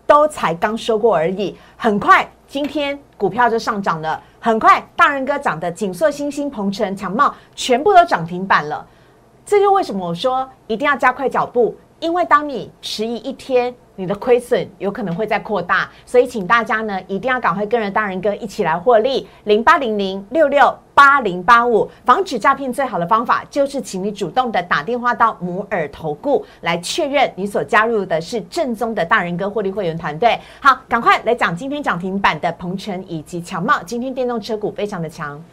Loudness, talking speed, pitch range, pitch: -17 LUFS, 295 characters per minute, 195-275 Hz, 230 Hz